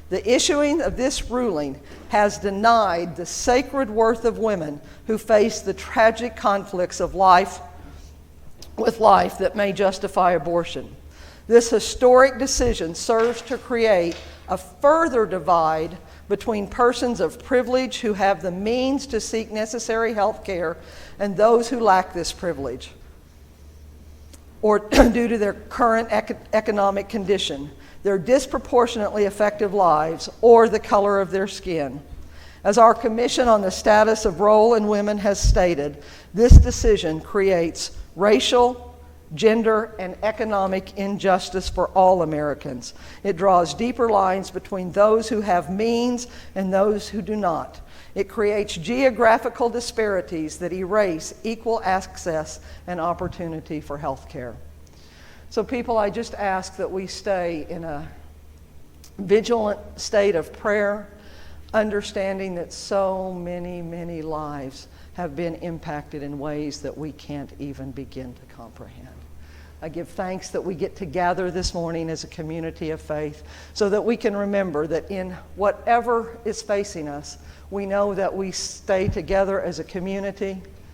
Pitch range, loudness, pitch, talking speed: 165-220 Hz, -21 LUFS, 195 Hz, 140 wpm